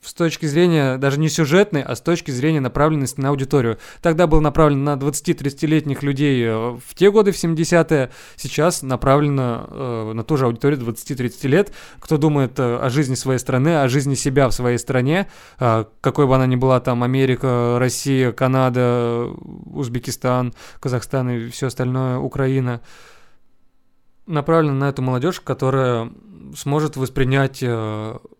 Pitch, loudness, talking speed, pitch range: 135 Hz, -19 LUFS, 150 wpm, 125-150 Hz